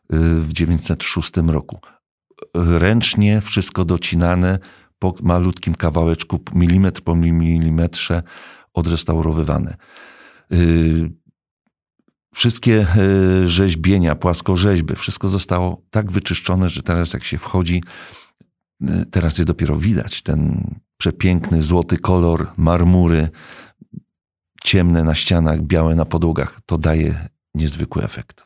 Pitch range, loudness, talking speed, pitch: 80-95 Hz, -17 LUFS, 95 wpm, 85 Hz